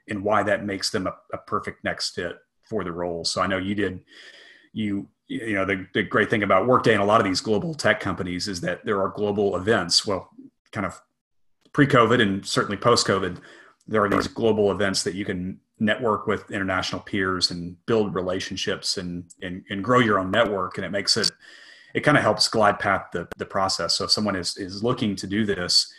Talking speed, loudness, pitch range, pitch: 215 wpm, -23 LUFS, 95-105 Hz, 100 Hz